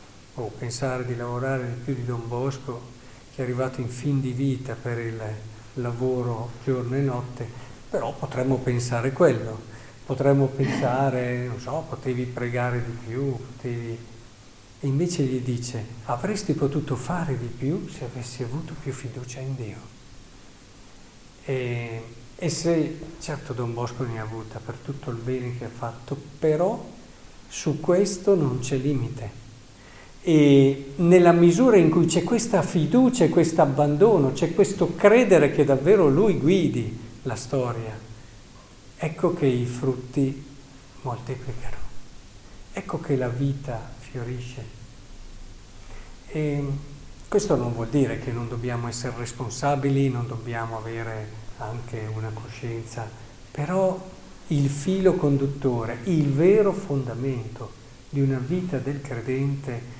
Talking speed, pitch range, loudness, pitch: 130 wpm, 115-140 Hz, -24 LUFS, 125 Hz